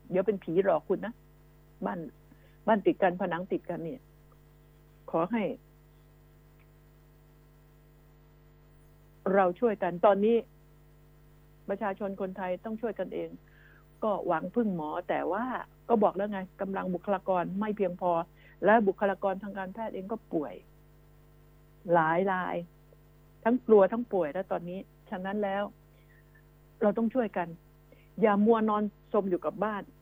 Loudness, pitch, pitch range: -30 LUFS, 185 Hz, 150-205 Hz